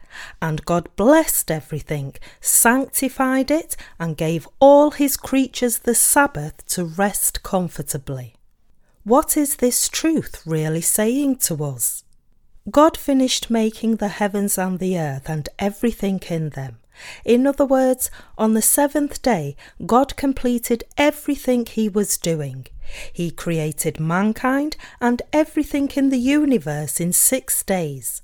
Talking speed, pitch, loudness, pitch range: 130 wpm, 220 Hz, -19 LUFS, 165-270 Hz